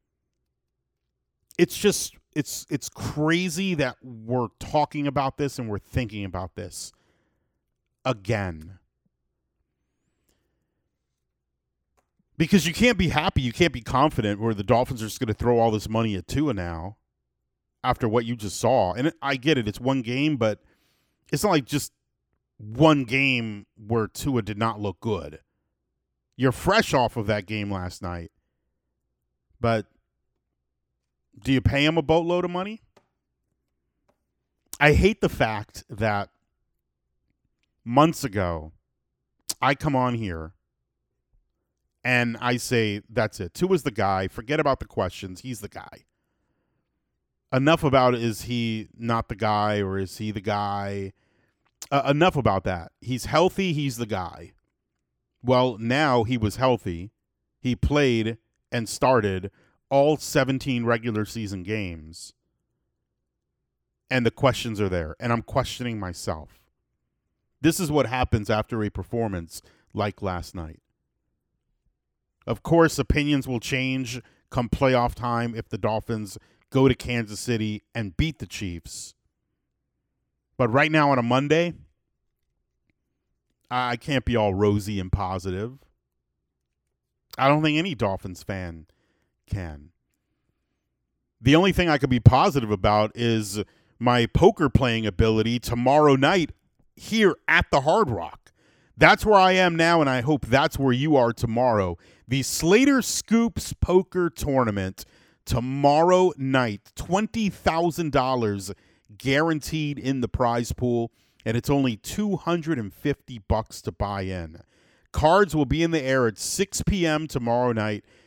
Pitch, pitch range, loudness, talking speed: 120 Hz, 100-140 Hz, -24 LUFS, 135 wpm